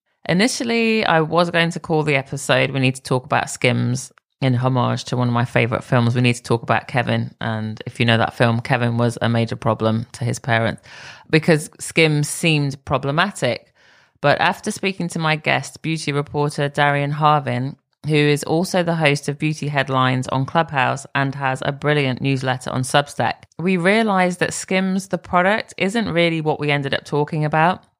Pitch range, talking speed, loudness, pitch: 125-160 Hz, 185 wpm, -19 LUFS, 145 Hz